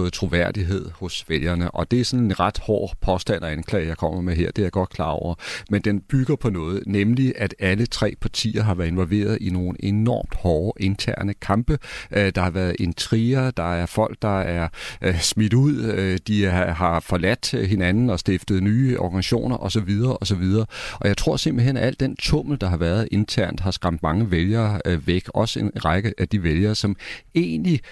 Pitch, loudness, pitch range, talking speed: 100 Hz, -22 LUFS, 90-115 Hz, 190 wpm